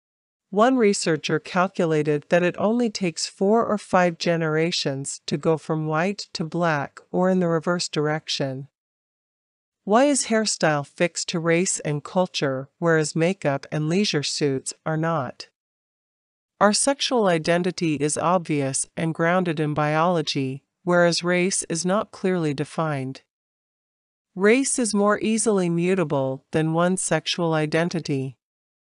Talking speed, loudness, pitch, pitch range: 125 wpm, -22 LUFS, 170 Hz, 155-185 Hz